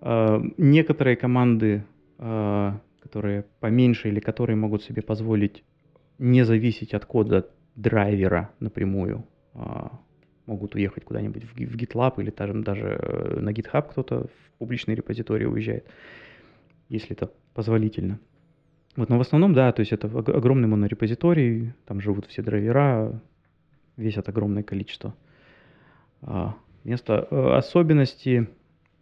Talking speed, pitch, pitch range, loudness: 105 wpm, 115 Hz, 105-130 Hz, -24 LUFS